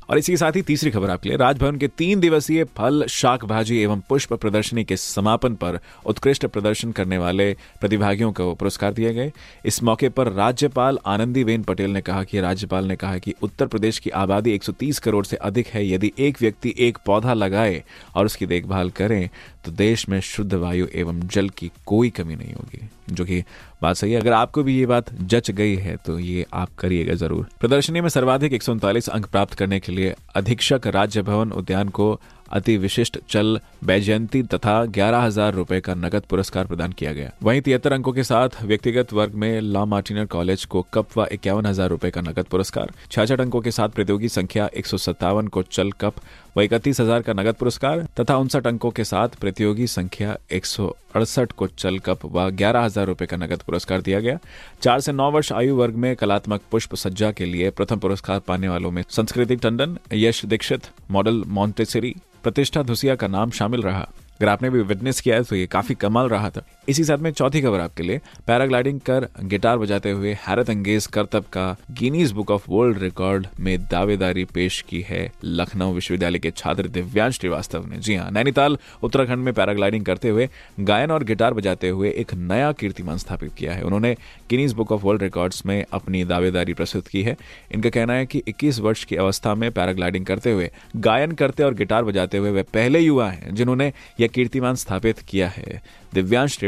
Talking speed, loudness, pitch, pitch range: 190 wpm, -21 LUFS, 105 Hz, 95-120 Hz